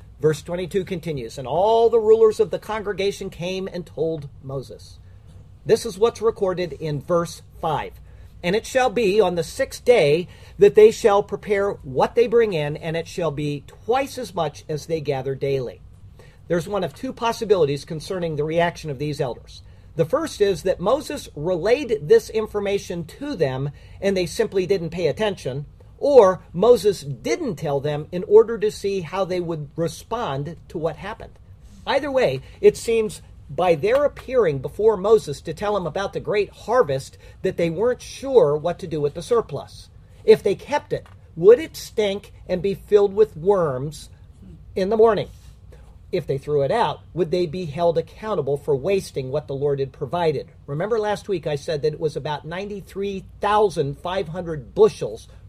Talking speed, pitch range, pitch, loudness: 175 wpm, 150-220 Hz, 180 Hz, -22 LUFS